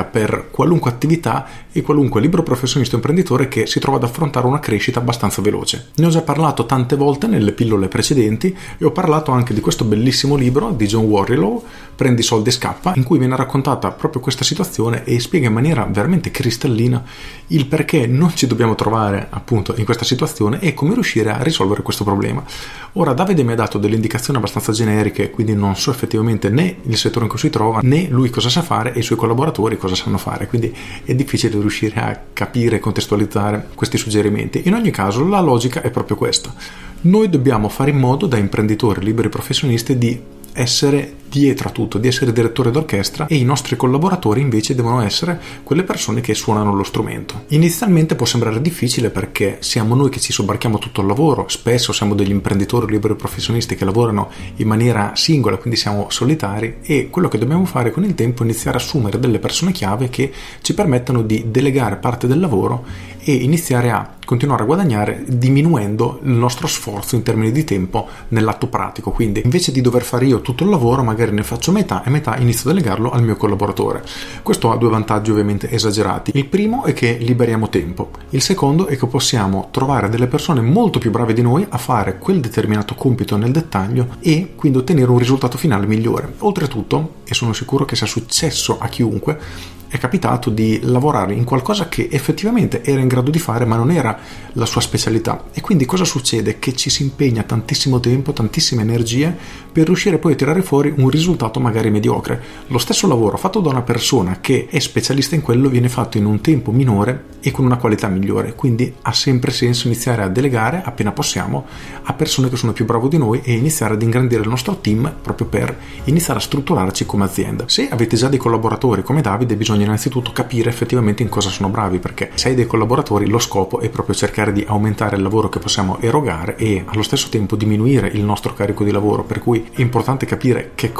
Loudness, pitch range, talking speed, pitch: -16 LUFS, 110-140 Hz, 200 wpm, 120 Hz